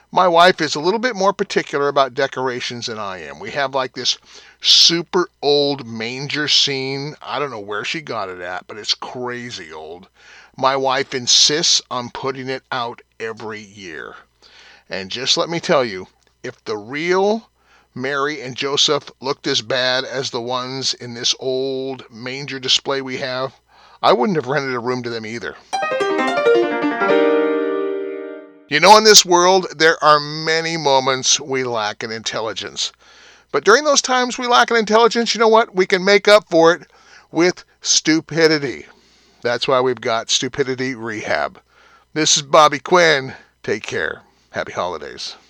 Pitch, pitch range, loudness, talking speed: 140 Hz, 125-170 Hz, -17 LUFS, 165 wpm